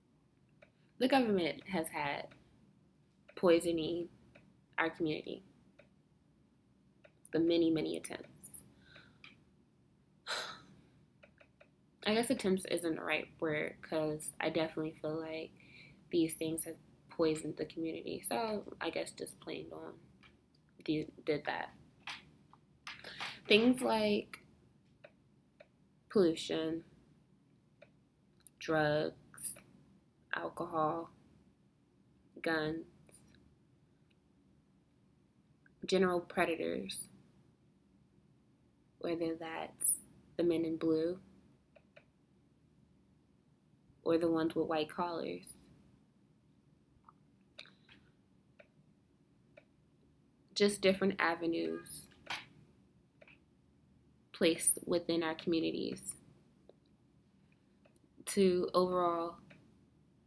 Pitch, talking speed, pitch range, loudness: 165 Hz, 65 wpm, 155-175 Hz, -35 LUFS